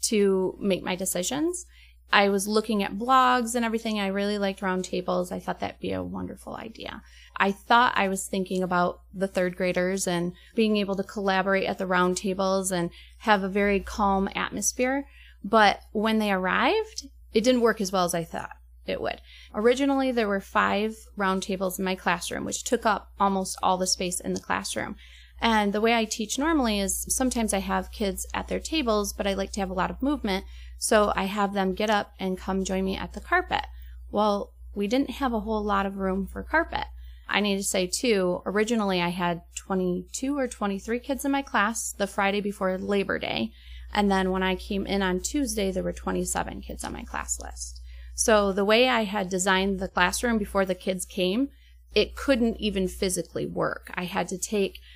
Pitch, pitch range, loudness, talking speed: 195 Hz, 185-220 Hz, -26 LUFS, 200 wpm